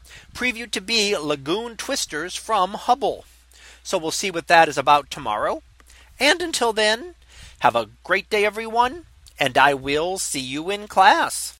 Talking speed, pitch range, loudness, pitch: 155 wpm, 150-235 Hz, -21 LUFS, 200 Hz